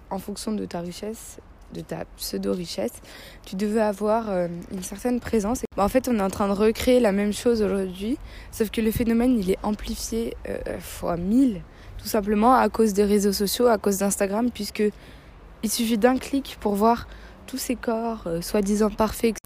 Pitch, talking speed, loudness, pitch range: 215 Hz, 180 wpm, -24 LUFS, 200-230 Hz